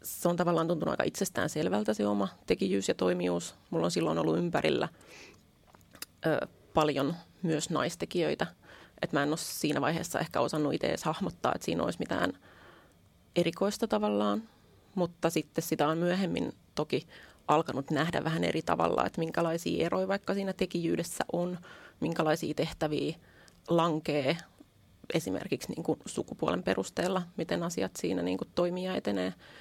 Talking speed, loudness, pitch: 140 wpm, -32 LUFS, 155 Hz